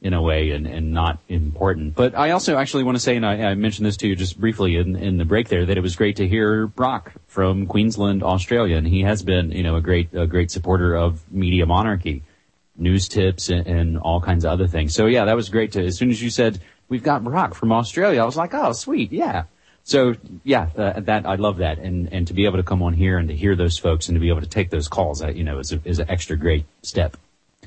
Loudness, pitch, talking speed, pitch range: -20 LUFS, 95 Hz, 265 wpm, 85-105 Hz